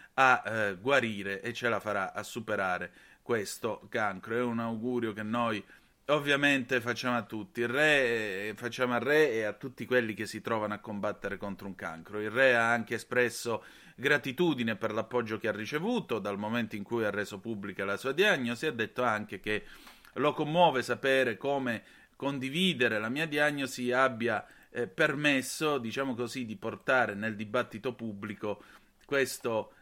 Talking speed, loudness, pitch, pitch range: 165 wpm, -31 LUFS, 120 Hz, 110-130 Hz